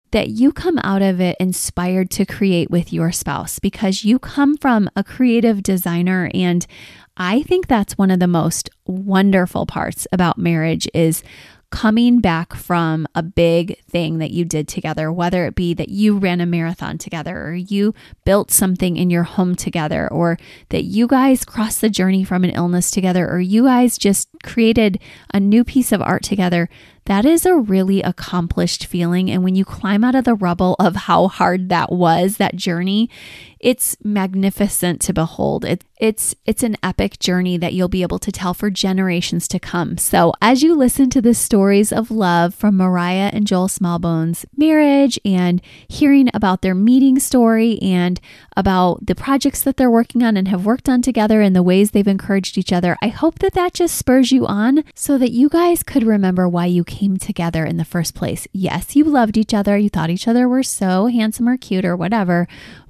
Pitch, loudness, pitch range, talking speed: 195 Hz, -16 LUFS, 175-230 Hz, 190 wpm